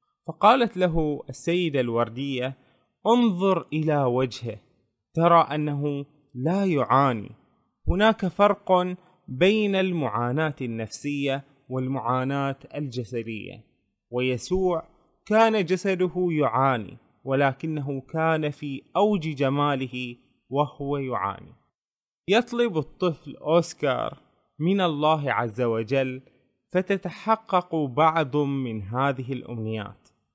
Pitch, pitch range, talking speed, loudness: 145 Hz, 130-180 Hz, 80 wpm, -25 LUFS